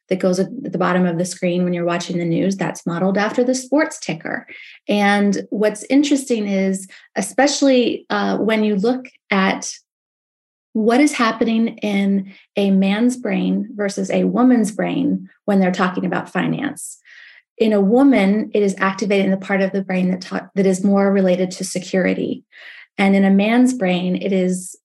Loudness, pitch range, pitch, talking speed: -18 LUFS, 185-230 Hz, 195 Hz, 170 wpm